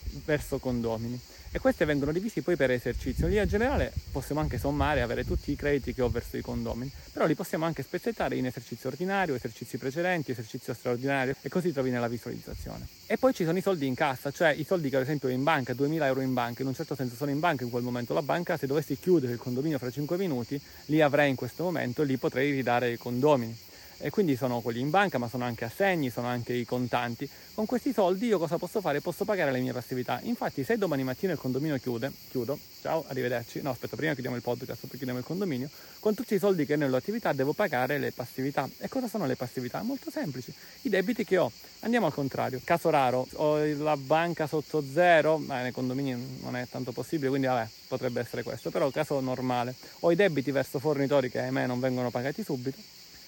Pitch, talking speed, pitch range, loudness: 140 Hz, 225 wpm, 125-165 Hz, -30 LUFS